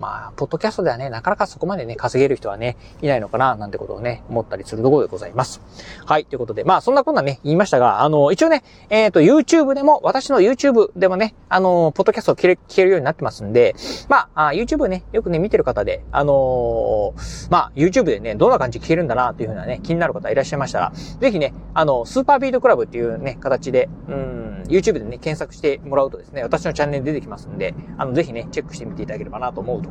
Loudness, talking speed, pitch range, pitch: -18 LUFS, 570 characters per minute, 140-225 Hz, 170 Hz